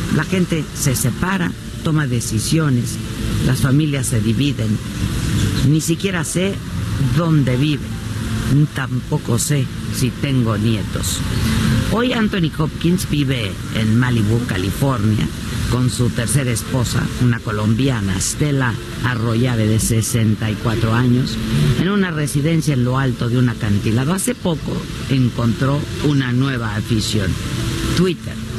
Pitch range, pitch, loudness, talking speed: 110-140 Hz, 125 Hz, -18 LUFS, 115 wpm